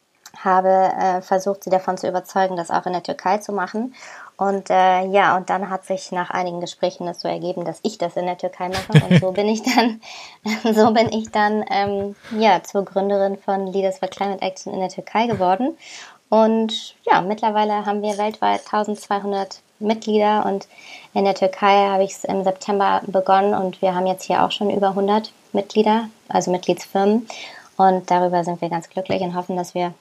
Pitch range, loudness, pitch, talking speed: 185-210 Hz, -20 LUFS, 195 Hz, 190 wpm